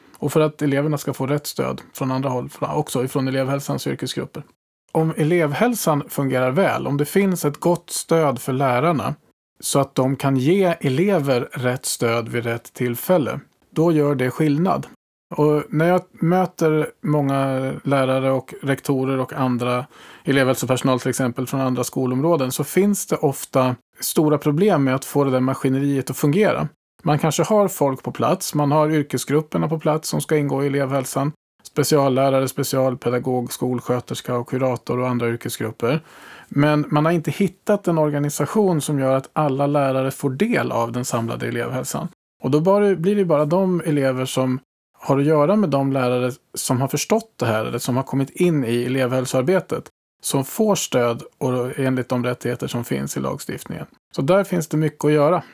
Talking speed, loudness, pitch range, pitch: 170 wpm, -20 LUFS, 130-155 Hz, 140 Hz